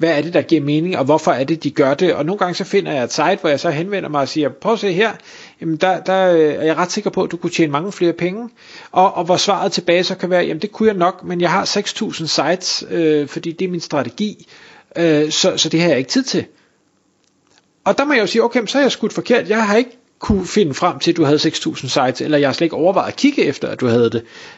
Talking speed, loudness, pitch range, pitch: 285 wpm, -16 LUFS, 160-205 Hz, 175 Hz